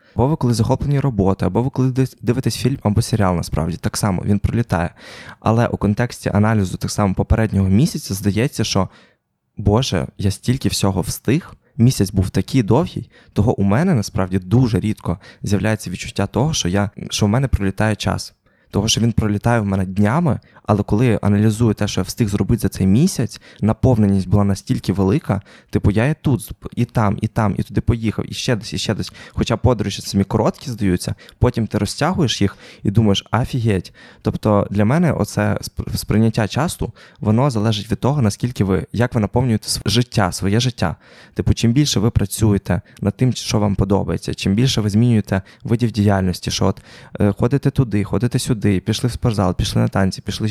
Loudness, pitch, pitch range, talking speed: -19 LUFS, 105 Hz, 100-120 Hz, 175 wpm